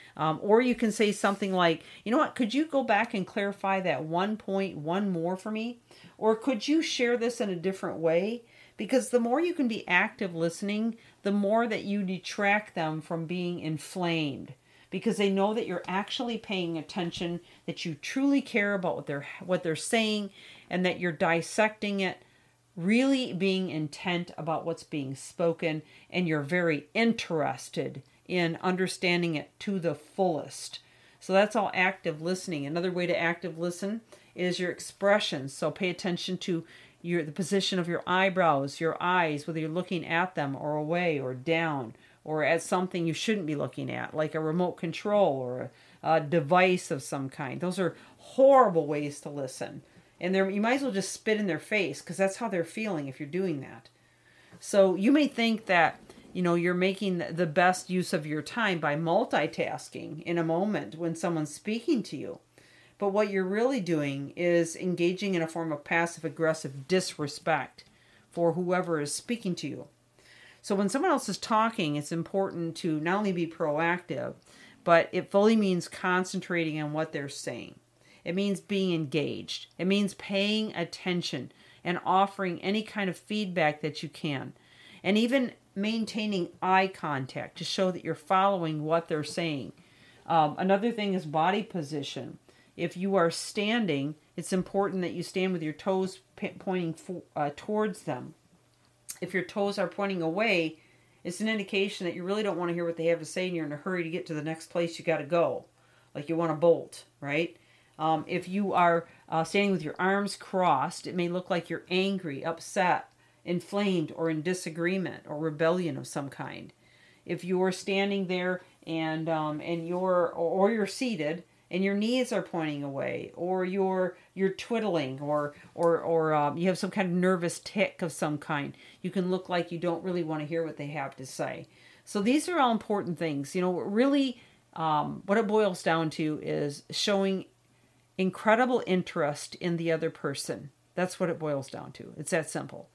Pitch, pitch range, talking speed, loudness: 180 Hz, 160-195 Hz, 185 wpm, -29 LUFS